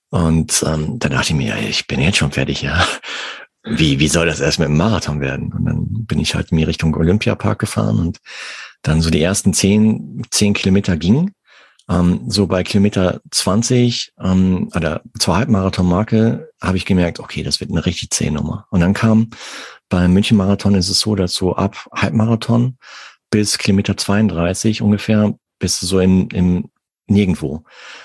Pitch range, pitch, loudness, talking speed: 90-110 Hz, 100 Hz, -16 LUFS, 165 wpm